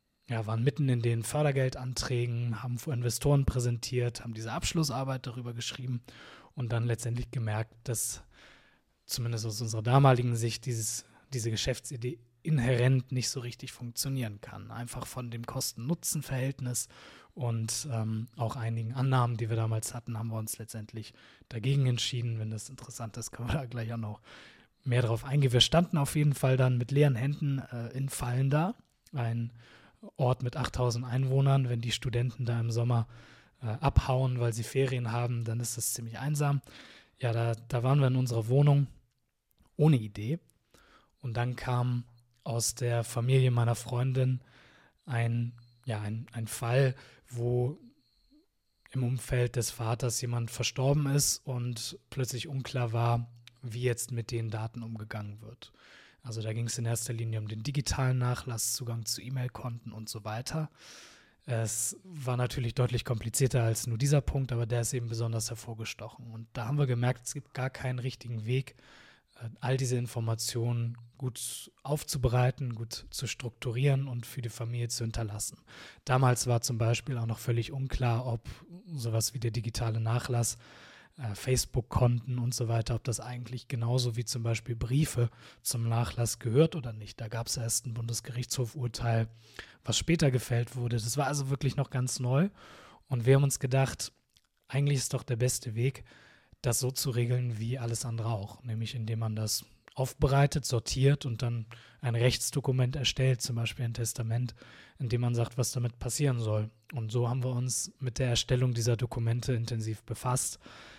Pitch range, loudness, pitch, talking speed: 115-130 Hz, -31 LUFS, 120 Hz, 165 wpm